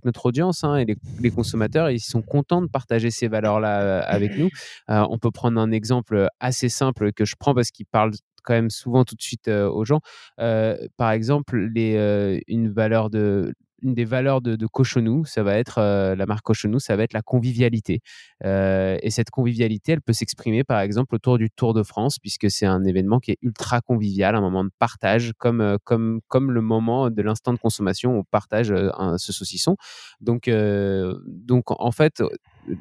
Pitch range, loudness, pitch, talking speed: 105-125 Hz, -22 LUFS, 115 Hz, 205 wpm